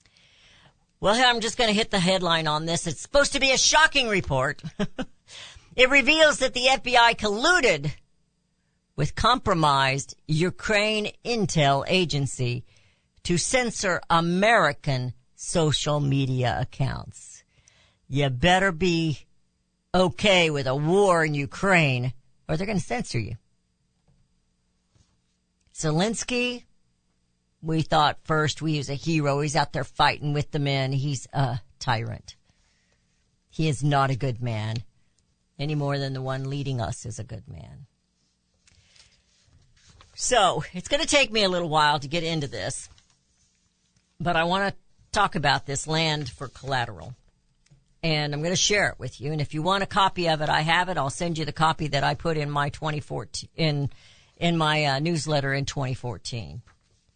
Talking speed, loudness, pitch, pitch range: 150 wpm, -24 LUFS, 150 Hz, 125-175 Hz